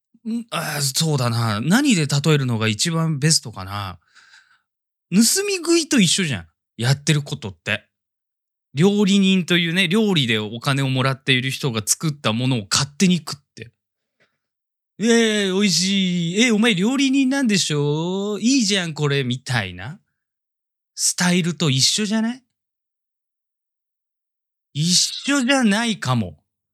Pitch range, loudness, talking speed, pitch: 130-205 Hz, -19 LUFS, 270 characters per minute, 160 Hz